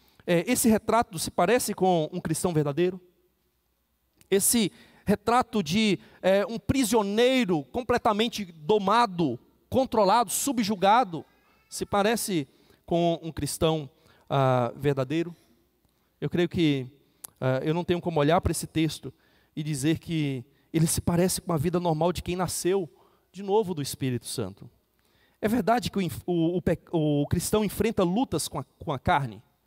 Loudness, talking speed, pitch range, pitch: -26 LUFS, 140 wpm, 155-210 Hz, 175 Hz